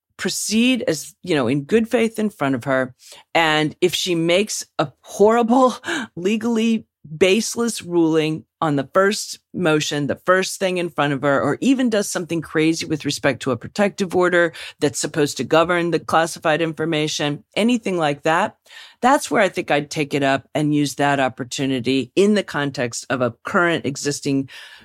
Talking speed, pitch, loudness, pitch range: 170 wpm, 160 Hz, -20 LUFS, 145-195 Hz